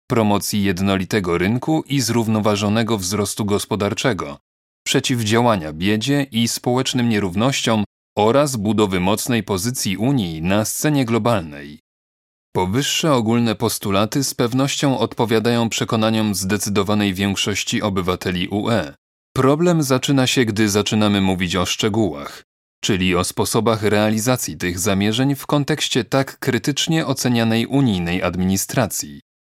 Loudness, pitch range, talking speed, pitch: -19 LUFS, 100-125 Hz, 105 wpm, 110 Hz